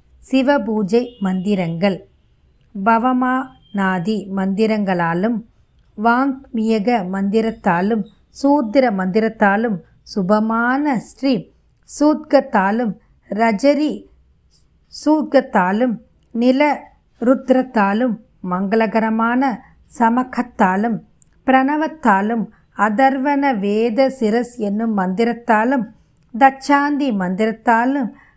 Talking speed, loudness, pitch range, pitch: 55 wpm, -18 LUFS, 205-265 Hz, 230 Hz